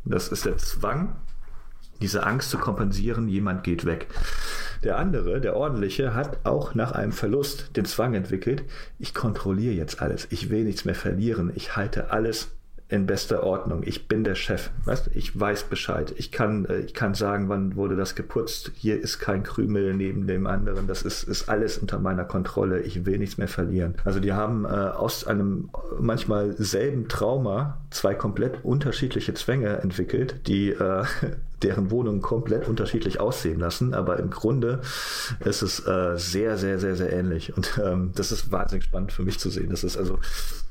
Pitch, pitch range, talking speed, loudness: 100 Hz, 95-110 Hz, 175 wpm, -27 LUFS